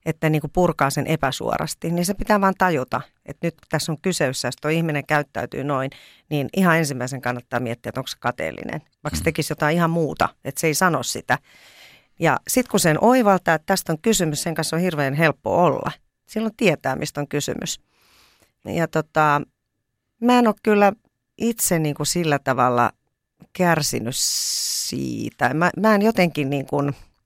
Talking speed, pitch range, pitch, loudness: 180 wpm, 135-180 Hz, 155 Hz, -21 LUFS